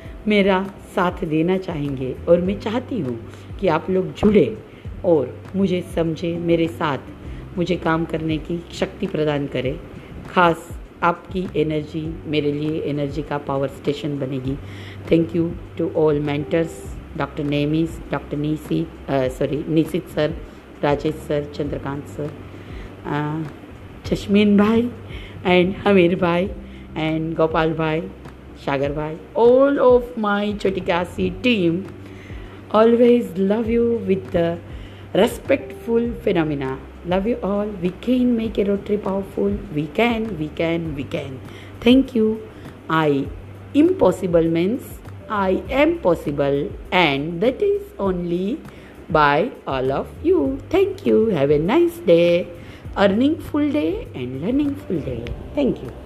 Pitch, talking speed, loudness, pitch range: 170 Hz, 125 wpm, -20 LUFS, 145-205 Hz